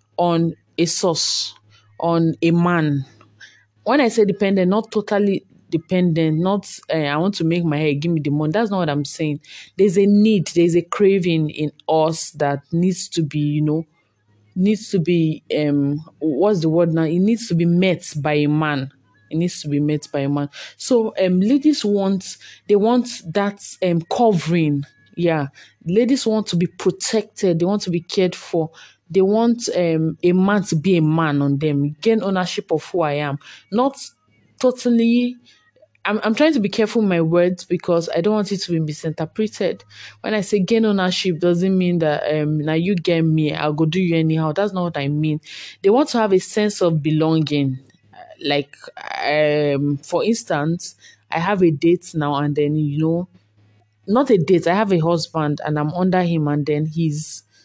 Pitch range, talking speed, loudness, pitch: 150-195 Hz, 190 wpm, -19 LUFS, 170 Hz